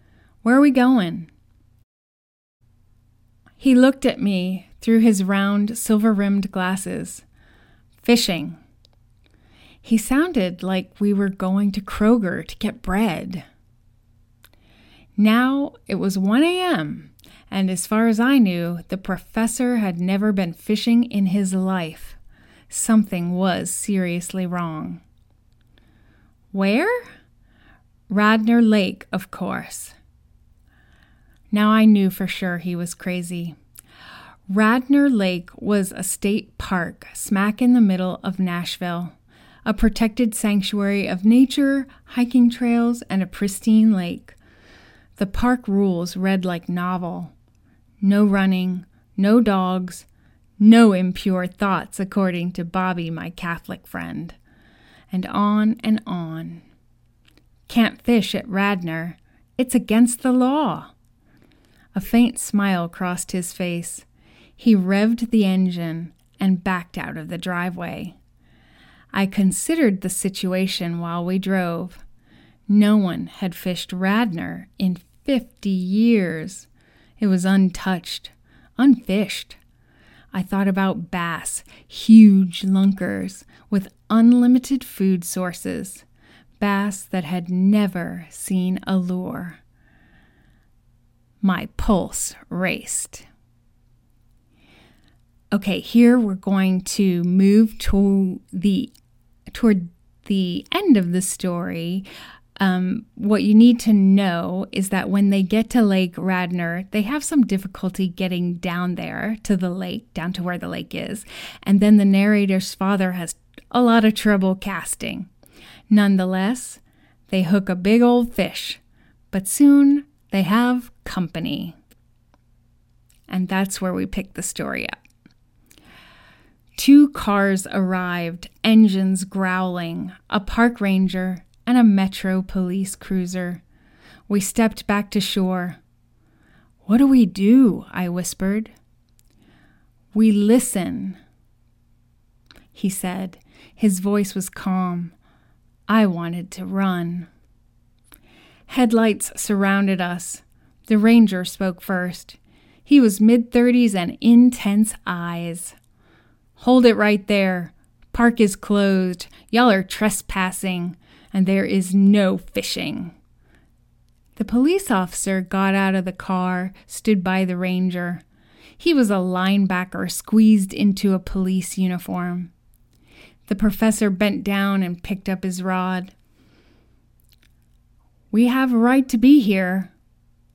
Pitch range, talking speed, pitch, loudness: 175-215 Hz, 115 wpm, 190 Hz, -20 LUFS